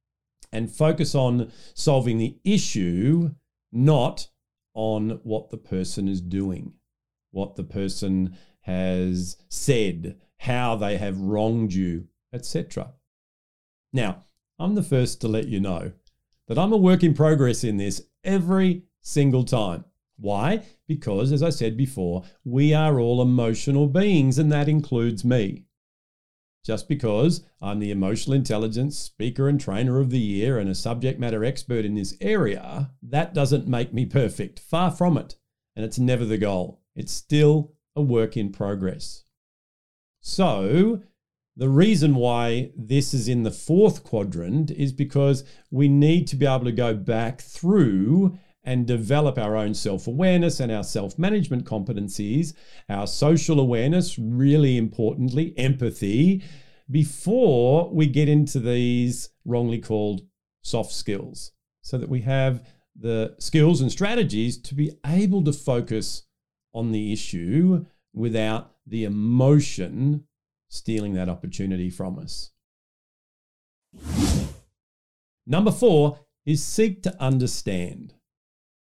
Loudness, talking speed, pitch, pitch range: -23 LUFS, 130 wpm, 125 Hz, 110-150 Hz